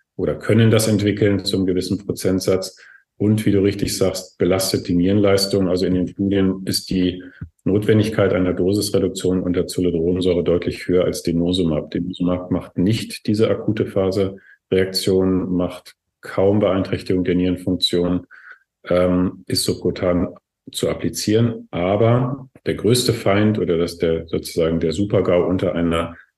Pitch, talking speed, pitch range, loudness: 95 Hz, 135 wpm, 90-100 Hz, -19 LUFS